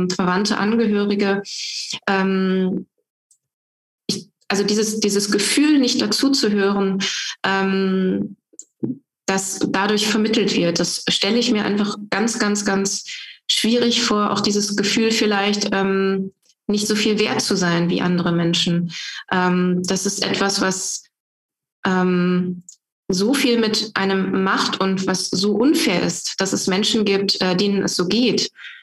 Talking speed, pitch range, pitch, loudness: 135 wpm, 190-215 Hz, 200 Hz, -19 LUFS